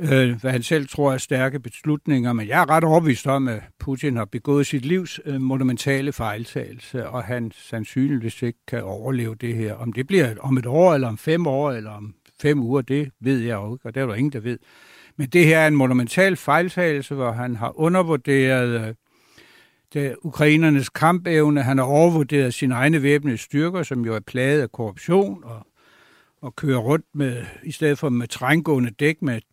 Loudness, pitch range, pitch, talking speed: -21 LUFS, 120-150 Hz, 135 Hz, 190 wpm